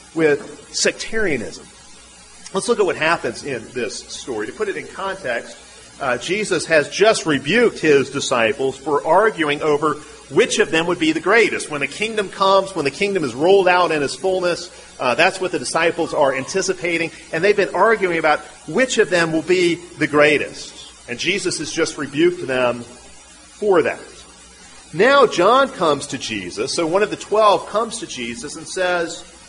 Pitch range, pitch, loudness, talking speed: 150-205 Hz, 170 Hz, -18 LUFS, 175 wpm